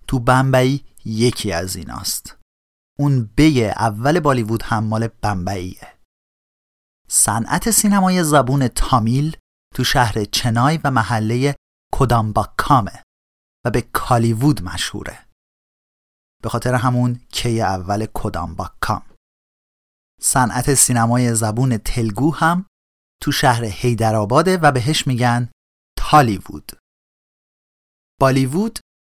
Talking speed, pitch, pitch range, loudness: 95 wpm, 120 Hz, 105-135 Hz, -17 LUFS